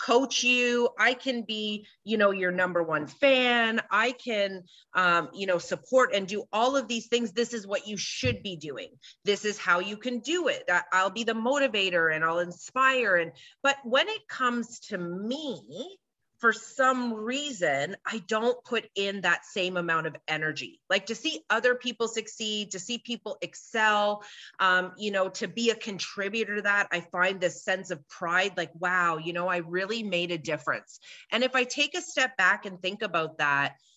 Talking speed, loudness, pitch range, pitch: 190 wpm, -27 LUFS, 180-240 Hz, 210 Hz